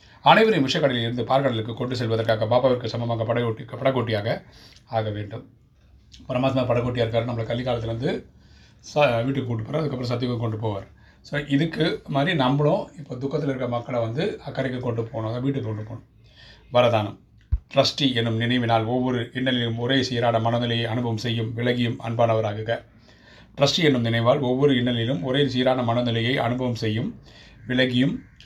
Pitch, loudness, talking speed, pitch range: 120 Hz, -23 LUFS, 135 wpm, 115-130 Hz